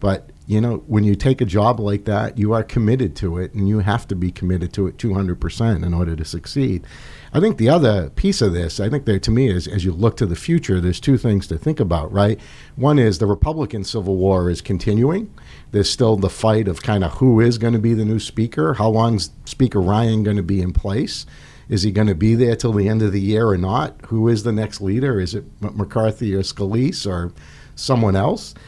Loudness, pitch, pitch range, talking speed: -19 LUFS, 105 Hz, 95-115 Hz, 230 wpm